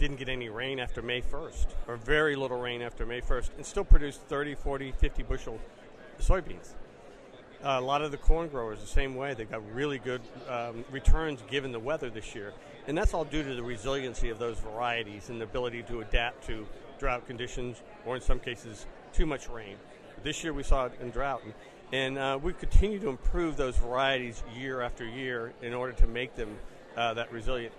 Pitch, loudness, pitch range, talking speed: 125 Hz, -33 LUFS, 120-140 Hz, 205 wpm